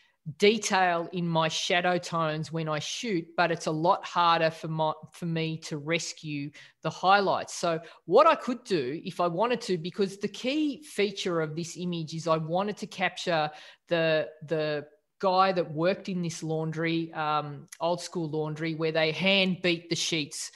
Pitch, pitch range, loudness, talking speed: 170 Hz, 160-185 Hz, -28 LUFS, 175 wpm